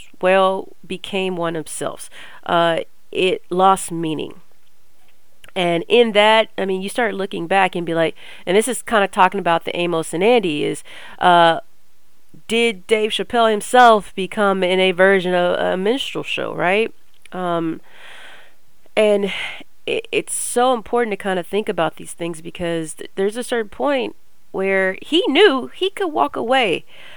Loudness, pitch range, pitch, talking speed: -18 LUFS, 180-235 Hz, 195 Hz, 160 wpm